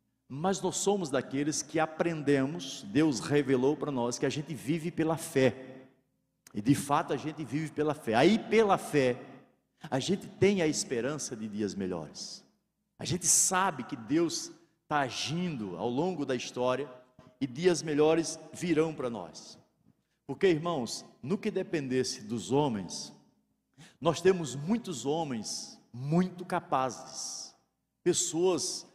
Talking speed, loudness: 135 wpm, -30 LUFS